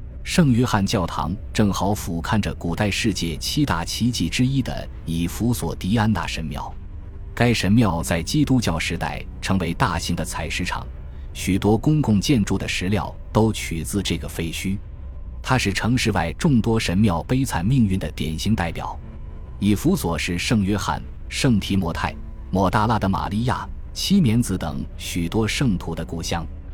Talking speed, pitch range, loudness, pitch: 245 characters per minute, 80-110 Hz, -22 LUFS, 95 Hz